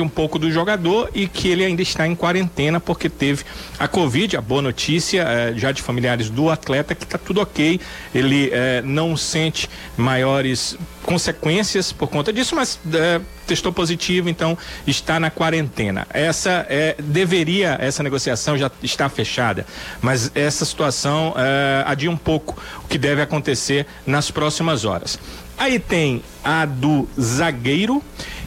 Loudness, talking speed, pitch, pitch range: -19 LUFS, 150 wpm, 155 Hz, 135-170 Hz